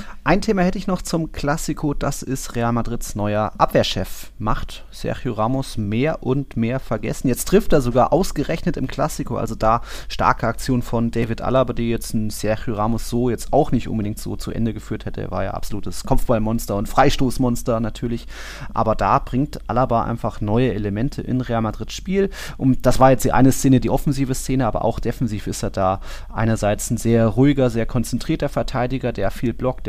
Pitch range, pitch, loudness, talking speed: 110-135 Hz, 120 Hz, -21 LUFS, 190 wpm